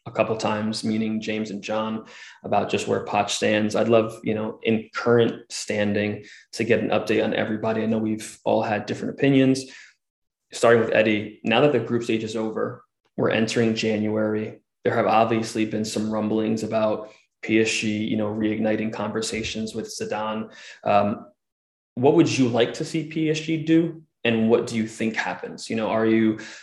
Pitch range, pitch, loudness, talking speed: 110-115 Hz, 110 Hz, -23 LUFS, 180 wpm